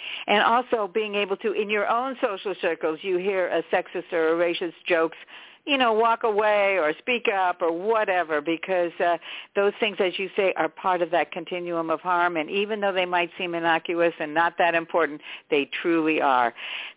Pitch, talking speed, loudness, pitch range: 180 Hz, 195 wpm, -24 LUFS, 165-205 Hz